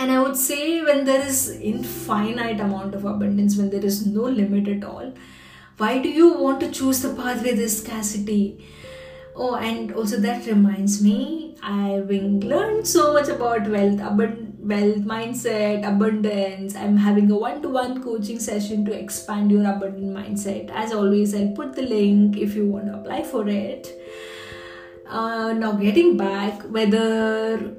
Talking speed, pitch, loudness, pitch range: 160 wpm, 210 Hz, -21 LUFS, 200-230 Hz